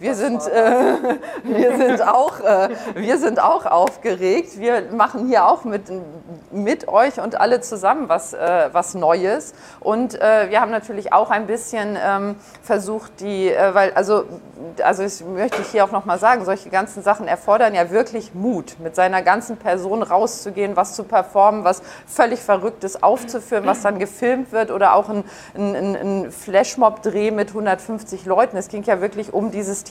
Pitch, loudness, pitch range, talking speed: 205 Hz, -18 LUFS, 195-220 Hz, 175 wpm